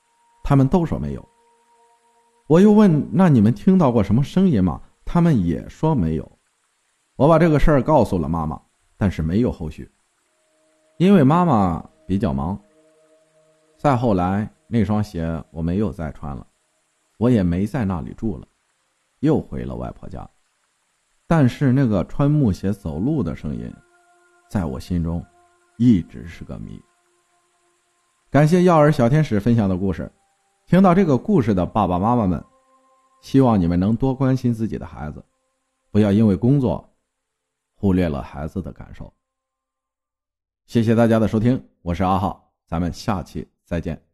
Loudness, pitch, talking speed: -19 LUFS, 120 Hz, 225 characters per minute